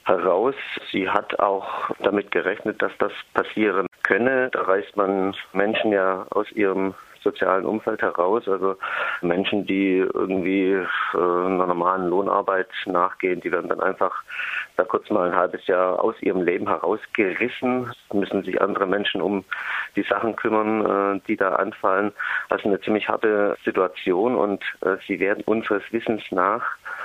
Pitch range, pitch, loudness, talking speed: 95-105 Hz, 100 Hz, -23 LUFS, 145 wpm